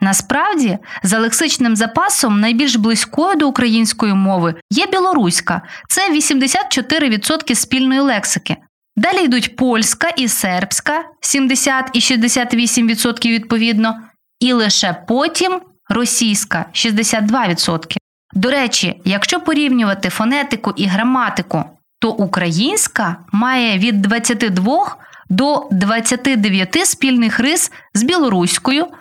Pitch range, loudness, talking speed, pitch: 205-275 Hz, -14 LUFS, 95 wpm, 235 Hz